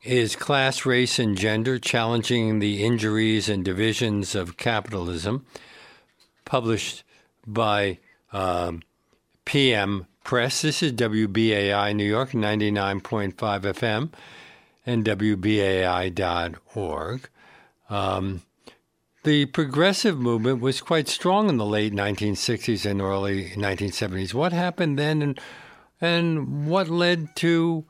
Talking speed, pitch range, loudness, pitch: 105 wpm, 100-135 Hz, -24 LUFS, 110 Hz